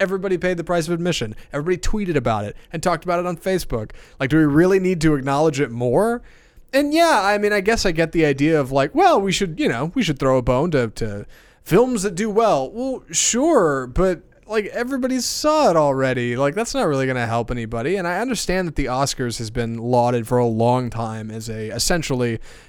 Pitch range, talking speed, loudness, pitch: 125-195 Hz, 225 wpm, -20 LUFS, 160 Hz